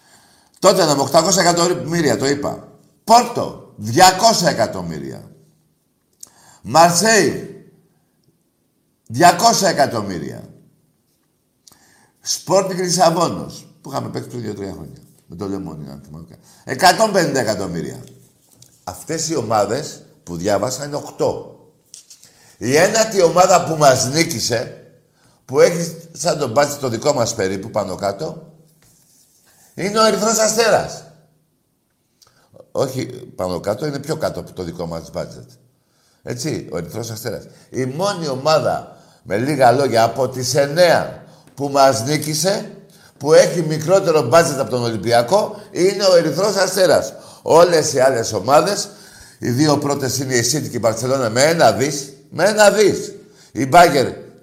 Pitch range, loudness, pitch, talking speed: 130-185 Hz, -16 LUFS, 160 Hz, 125 wpm